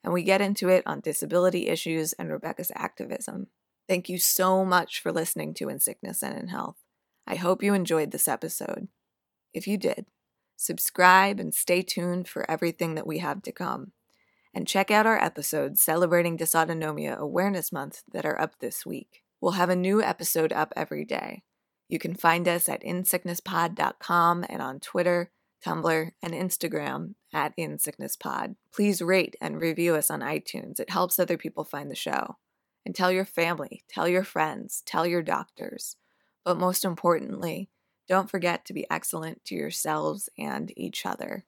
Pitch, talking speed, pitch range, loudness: 175 Hz, 170 wpm, 165-185 Hz, -27 LUFS